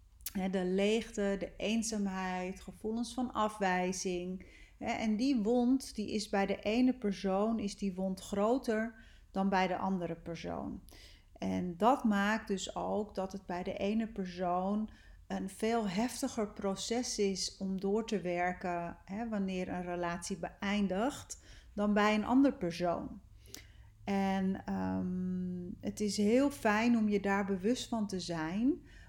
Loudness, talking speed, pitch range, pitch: -34 LUFS, 140 wpm, 185-220 Hz, 200 Hz